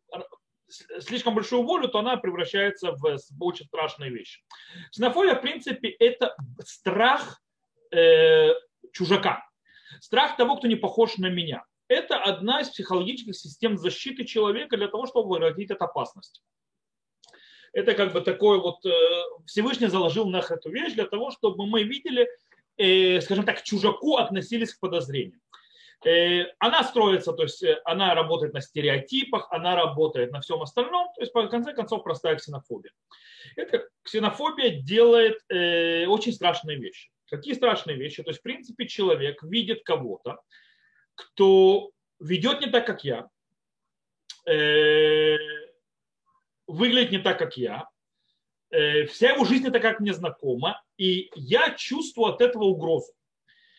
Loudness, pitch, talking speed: -24 LUFS, 230 Hz, 135 wpm